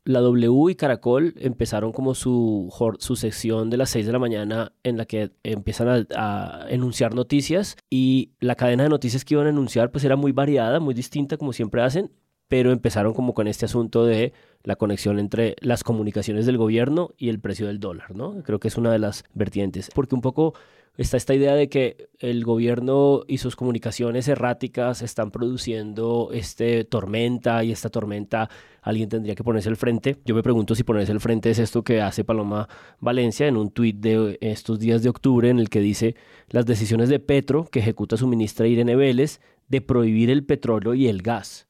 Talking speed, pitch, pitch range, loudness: 195 wpm, 120 Hz, 110-130 Hz, -22 LUFS